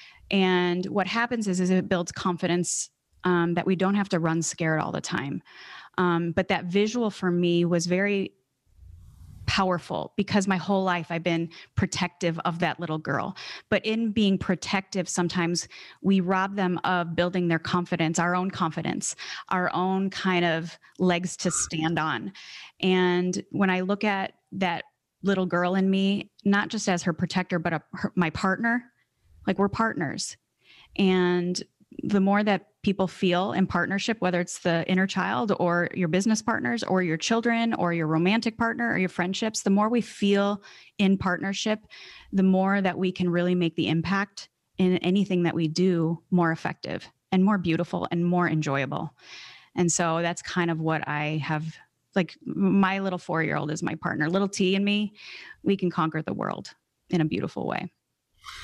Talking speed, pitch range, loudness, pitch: 175 wpm, 170-195 Hz, -26 LUFS, 180 Hz